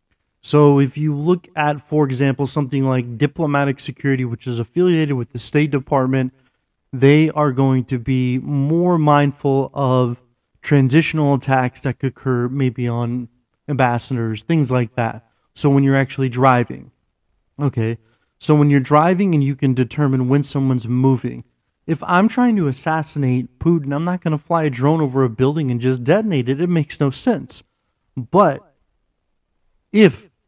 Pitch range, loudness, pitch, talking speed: 125-150 Hz, -18 LUFS, 135 Hz, 160 wpm